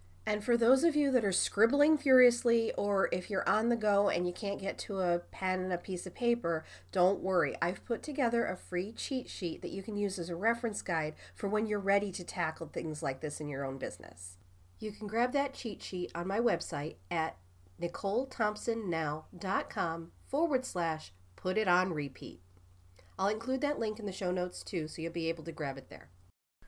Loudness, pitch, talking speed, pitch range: -33 LUFS, 185 Hz, 205 wpm, 160-220 Hz